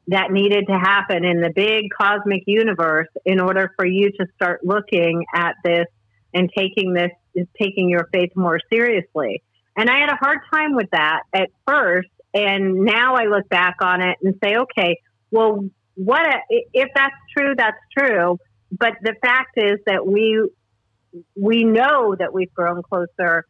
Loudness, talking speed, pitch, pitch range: -18 LUFS, 170 wpm, 190 Hz, 175-220 Hz